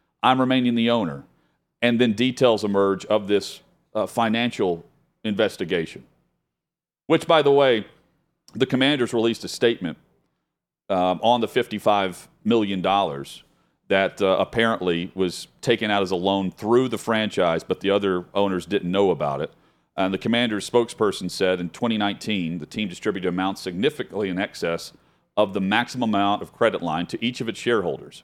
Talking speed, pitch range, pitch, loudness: 155 wpm, 95-120 Hz, 105 Hz, -23 LUFS